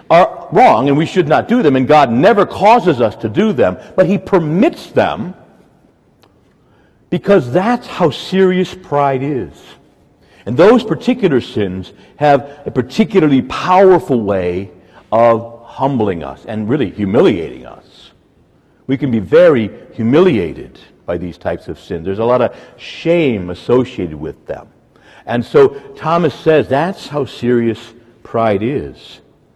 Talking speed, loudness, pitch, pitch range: 140 wpm, -13 LUFS, 140 Hz, 115-185 Hz